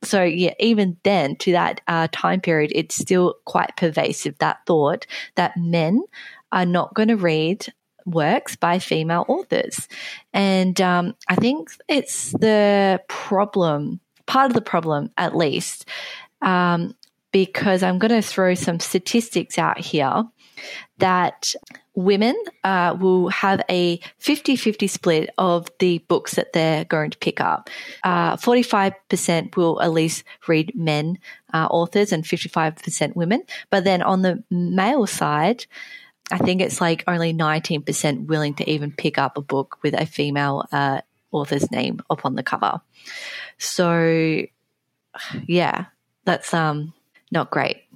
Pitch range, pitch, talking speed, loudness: 165-205 Hz, 180 Hz, 140 wpm, -21 LUFS